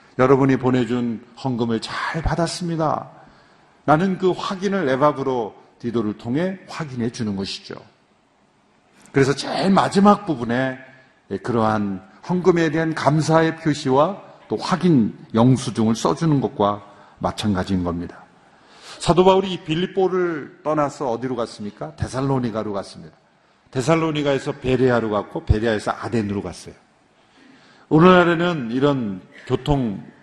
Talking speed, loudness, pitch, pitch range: 290 characters per minute, -20 LUFS, 130 Hz, 115-160 Hz